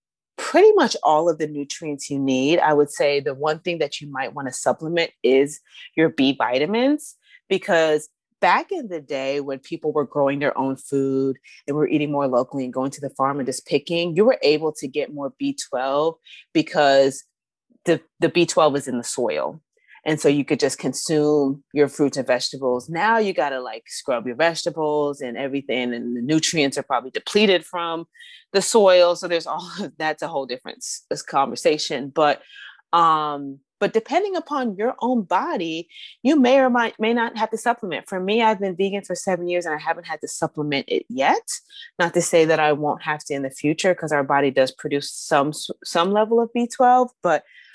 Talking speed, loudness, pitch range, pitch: 195 wpm, -21 LUFS, 140-200 Hz, 155 Hz